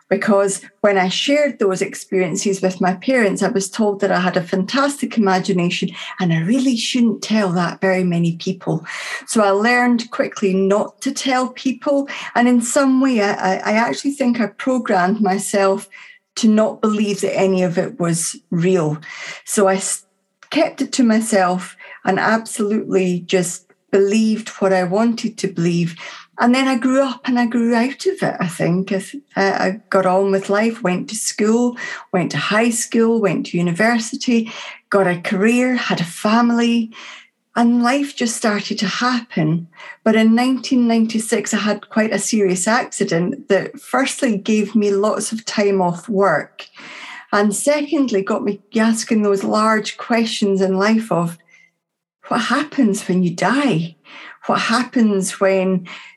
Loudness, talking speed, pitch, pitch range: -18 LUFS, 155 wpm, 210 Hz, 190-240 Hz